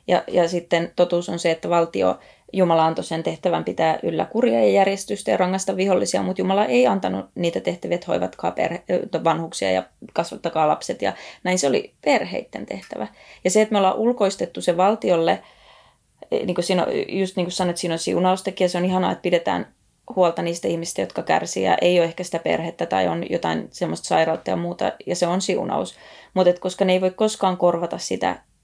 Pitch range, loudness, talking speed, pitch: 165-185 Hz, -22 LUFS, 190 wpm, 175 Hz